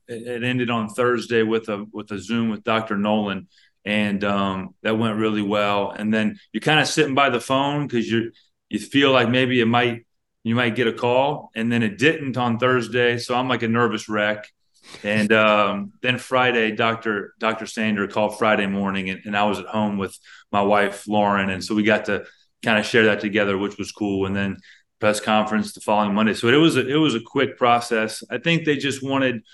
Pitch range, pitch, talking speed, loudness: 105-125 Hz, 110 Hz, 215 wpm, -21 LUFS